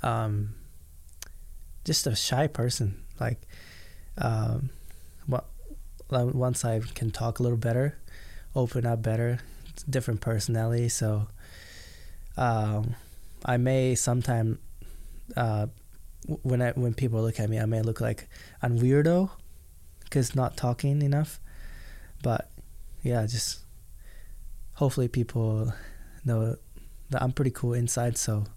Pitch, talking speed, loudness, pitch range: 115 Hz, 115 wpm, -28 LUFS, 80-125 Hz